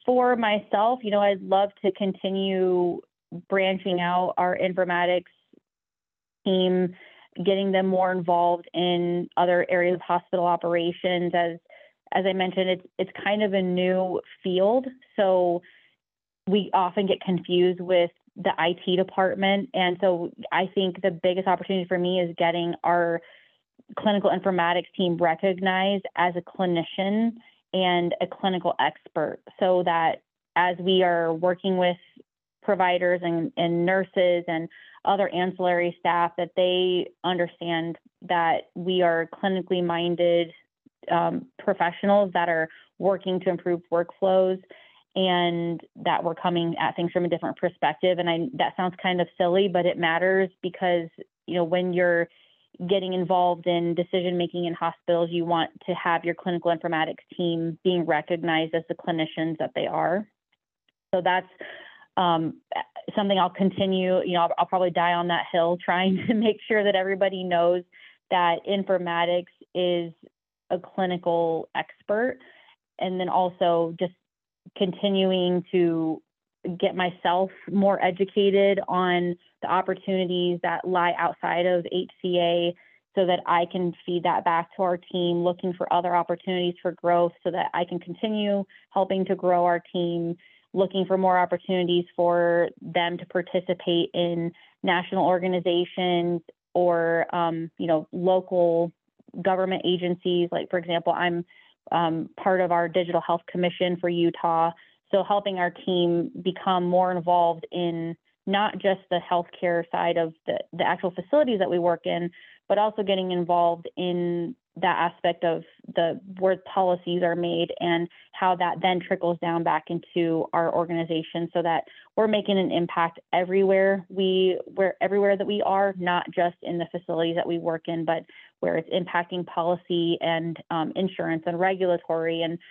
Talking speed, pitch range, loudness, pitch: 145 wpm, 170-185 Hz, -25 LUFS, 180 Hz